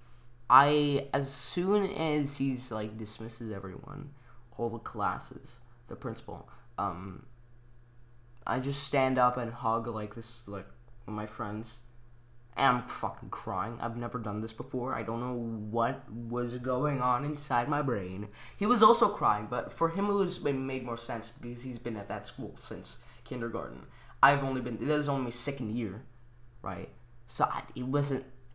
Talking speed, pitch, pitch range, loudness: 170 wpm, 120 Hz, 115-135 Hz, -31 LUFS